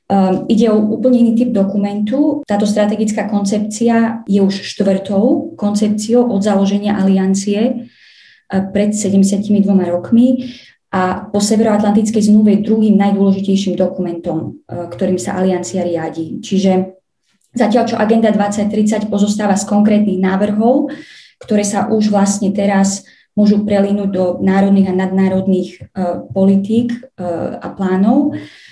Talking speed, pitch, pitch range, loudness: 110 wpm, 205 Hz, 190-220 Hz, -14 LUFS